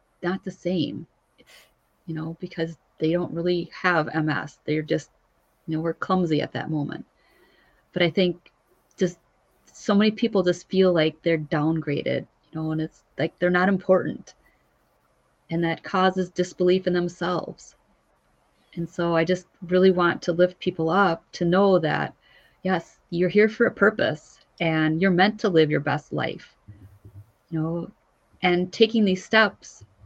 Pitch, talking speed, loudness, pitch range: 175 Hz, 160 wpm, -24 LUFS, 160-185 Hz